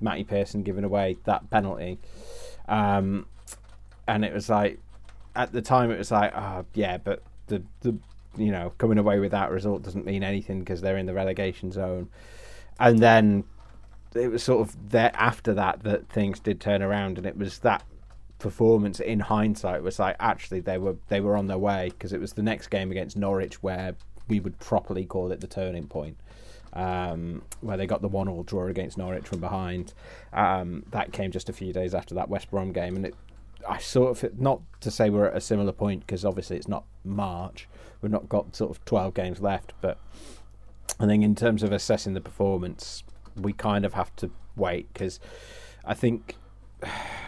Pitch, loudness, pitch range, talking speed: 100 Hz, -27 LUFS, 95-105 Hz, 195 wpm